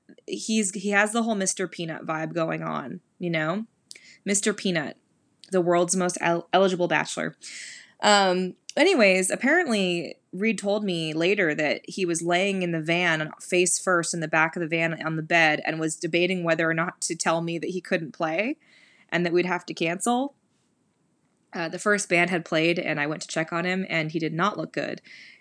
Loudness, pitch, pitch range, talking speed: -24 LUFS, 175 Hz, 165-195 Hz, 195 wpm